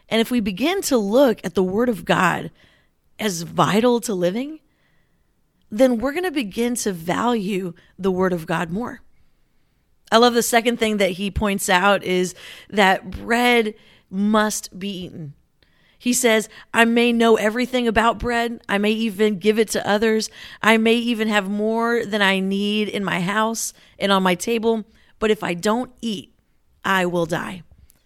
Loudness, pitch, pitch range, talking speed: -20 LUFS, 215 Hz, 195-235 Hz, 170 wpm